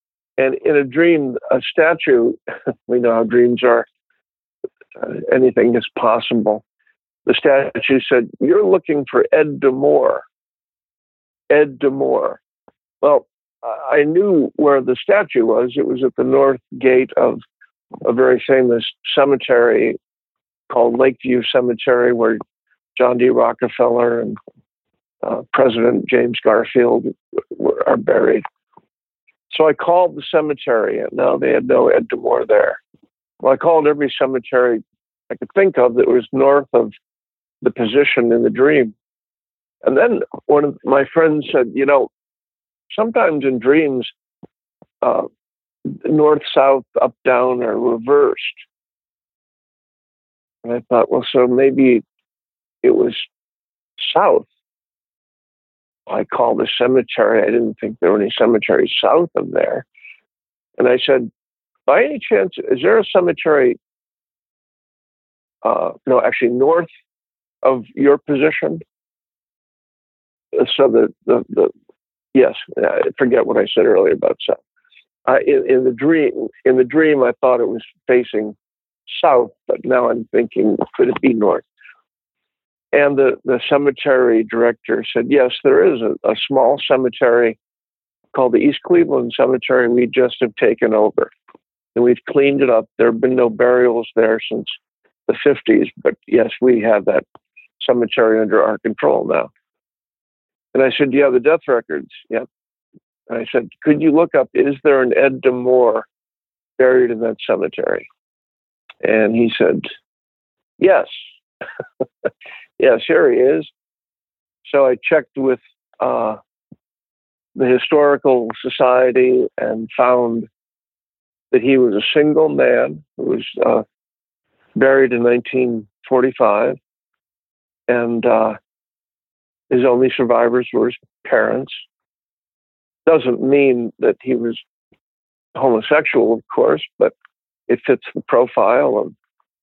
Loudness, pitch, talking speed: -15 LUFS, 140 Hz, 135 wpm